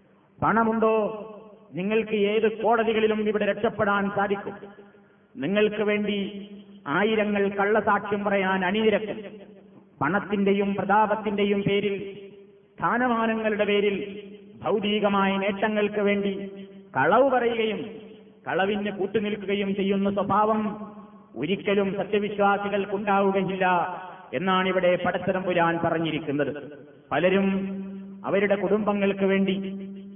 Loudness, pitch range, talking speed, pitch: -24 LUFS, 195-210 Hz, 75 wpm, 200 Hz